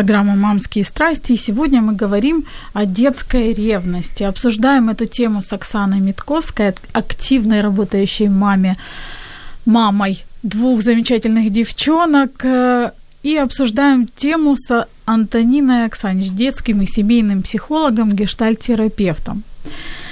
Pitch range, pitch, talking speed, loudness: 205-255 Hz, 225 Hz, 100 wpm, -15 LUFS